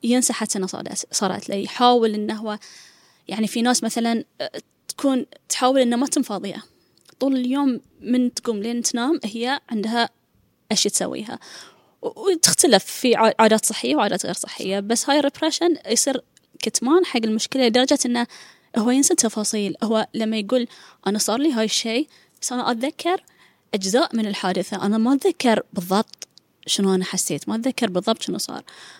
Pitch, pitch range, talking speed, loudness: 235 Hz, 215-265 Hz, 145 wpm, -21 LUFS